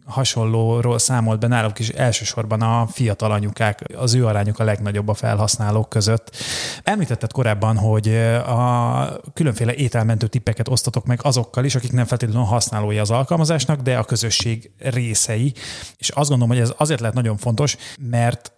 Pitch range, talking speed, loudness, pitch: 110-125 Hz, 155 wpm, -19 LUFS, 120 Hz